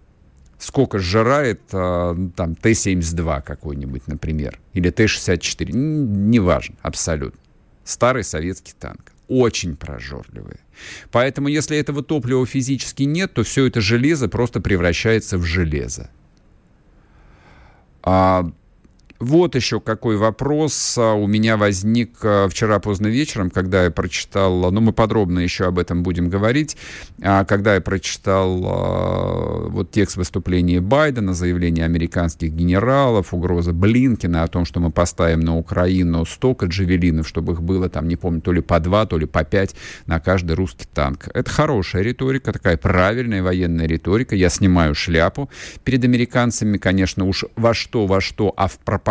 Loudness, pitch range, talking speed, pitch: -19 LUFS, 85-115 Hz, 140 wpm, 95 Hz